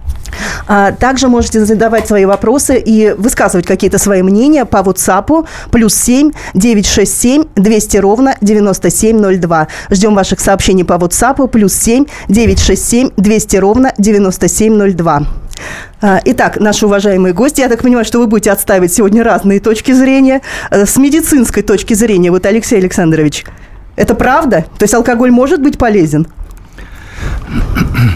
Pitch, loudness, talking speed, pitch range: 210 Hz, -9 LUFS, 125 wpm, 195-240 Hz